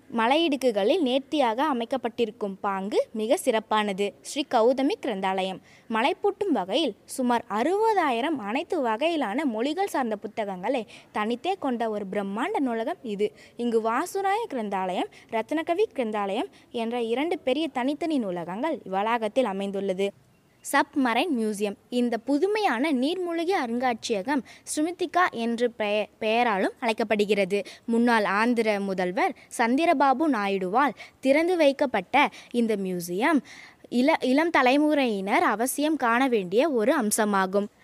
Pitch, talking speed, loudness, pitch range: 240 Hz, 100 wpm, -25 LUFS, 215-295 Hz